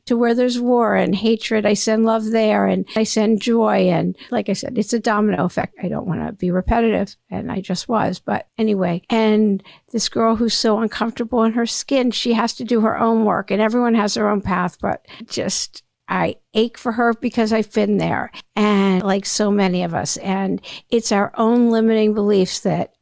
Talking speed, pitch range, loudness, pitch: 205 wpm, 200-230 Hz, -19 LUFS, 220 Hz